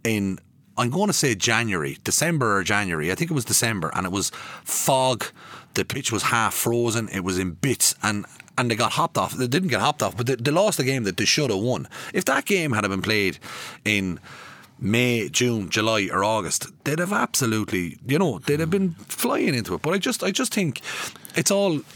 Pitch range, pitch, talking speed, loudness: 100-145 Hz, 115 Hz, 215 wpm, -23 LUFS